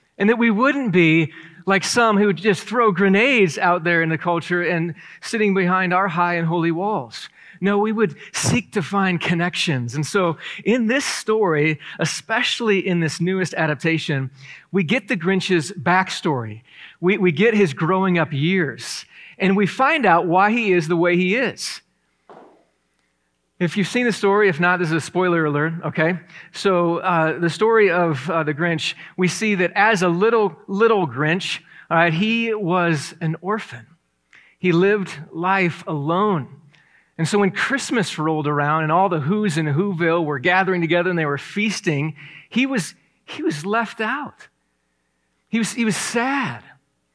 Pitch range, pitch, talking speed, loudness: 160-205 Hz, 180 Hz, 170 wpm, -19 LUFS